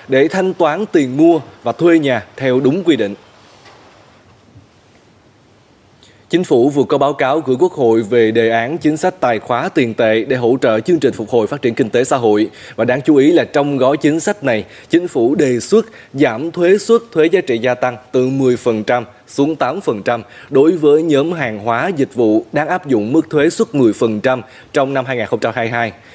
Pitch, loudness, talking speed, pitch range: 130 Hz, -14 LUFS, 195 wpm, 115-160 Hz